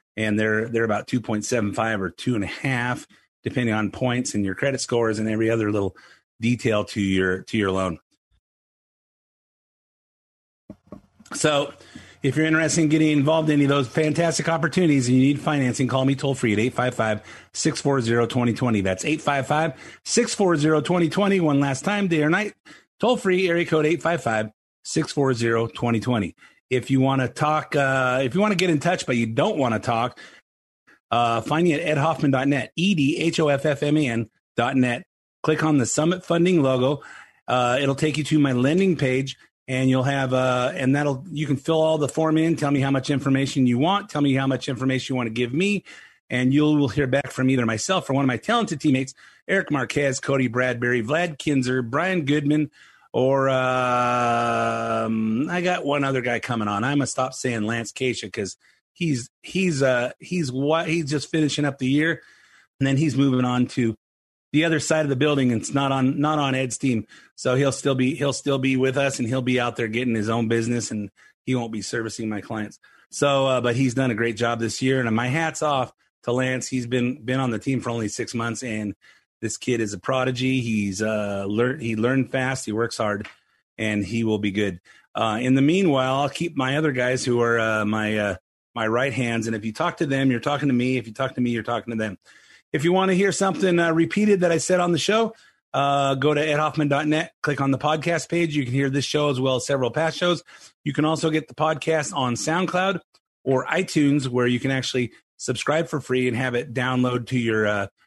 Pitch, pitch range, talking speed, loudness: 130 Hz, 120-150 Hz, 210 wpm, -22 LUFS